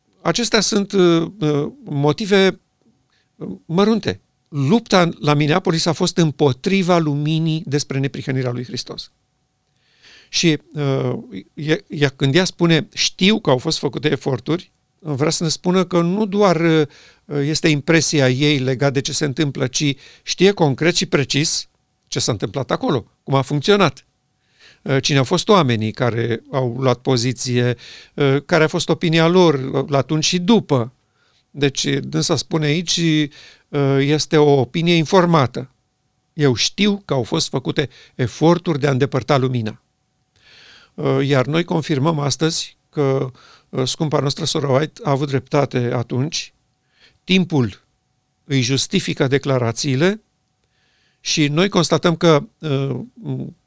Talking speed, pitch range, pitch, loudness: 120 wpm, 135-170 Hz, 150 Hz, -18 LUFS